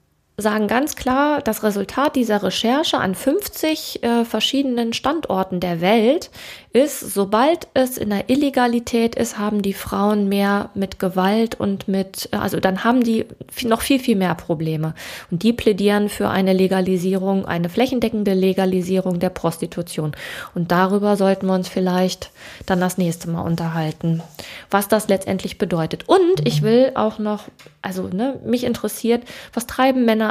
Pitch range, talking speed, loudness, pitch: 185-235 Hz, 150 wpm, -19 LUFS, 205 Hz